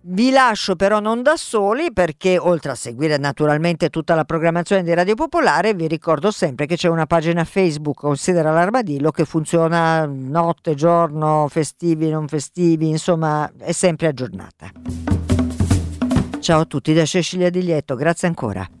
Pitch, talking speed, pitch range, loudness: 165 Hz, 150 wpm, 150-180 Hz, -18 LUFS